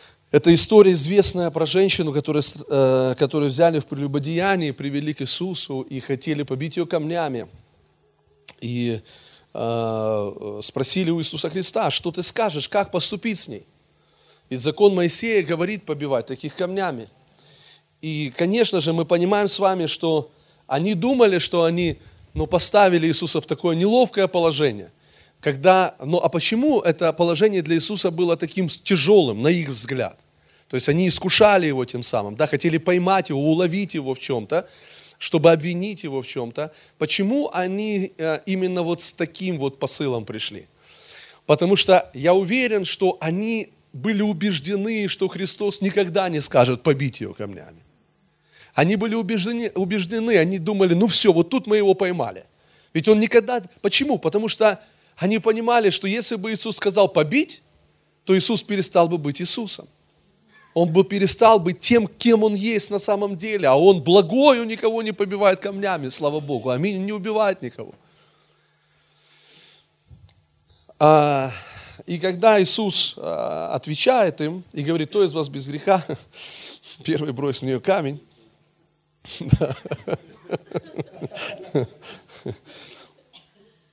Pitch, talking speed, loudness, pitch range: 175 Hz, 135 wpm, -20 LUFS, 150-200 Hz